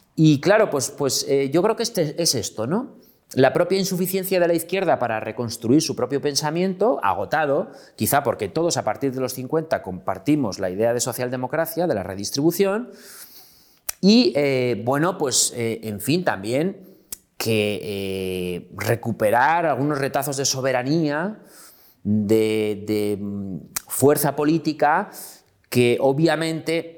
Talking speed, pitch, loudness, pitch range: 135 wpm, 140 Hz, -21 LUFS, 115-165 Hz